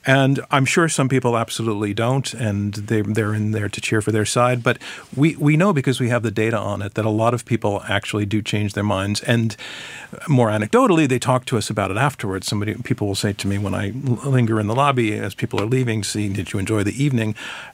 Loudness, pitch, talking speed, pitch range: -20 LUFS, 110 Hz, 235 wpm, 105-130 Hz